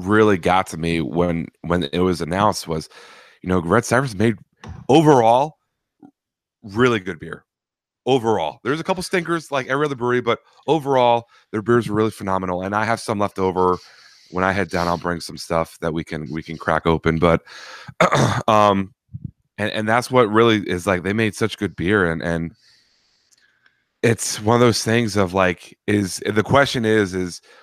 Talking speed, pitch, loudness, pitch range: 180 wpm, 100 Hz, -19 LUFS, 85-115 Hz